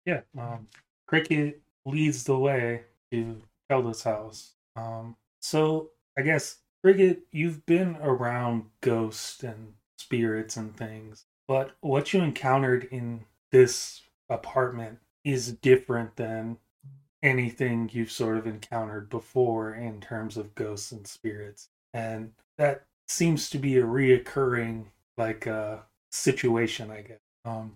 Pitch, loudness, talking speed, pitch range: 115 Hz, -27 LUFS, 125 wpm, 110-135 Hz